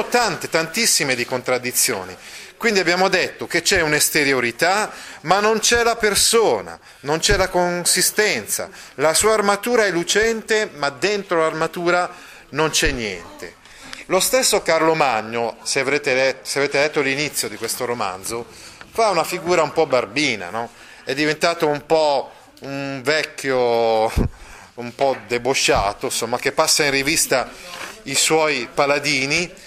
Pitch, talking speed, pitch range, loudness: 155 Hz, 135 wpm, 135-185 Hz, -18 LUFS